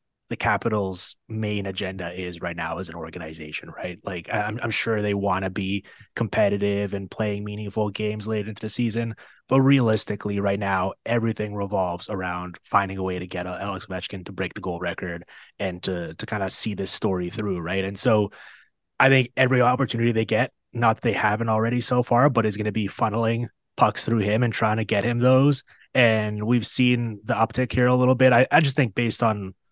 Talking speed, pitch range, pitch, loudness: 205 wpm, 95-115 Hz, 105 Hz, -24 LUFS